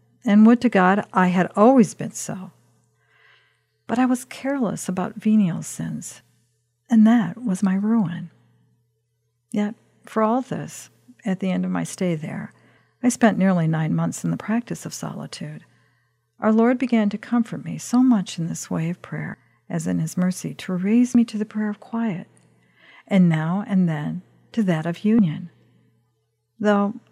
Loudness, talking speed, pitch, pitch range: -21 LUFS, 170 wpm, 190 Hz, 155-220 Hz